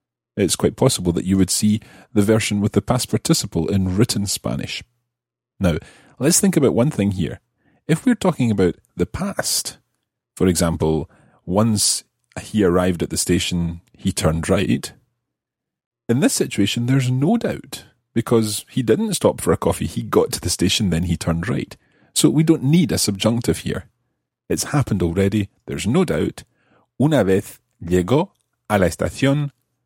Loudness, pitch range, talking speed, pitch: -19 LUFS, 90-125 Hz, 165 wpm, 105 Hz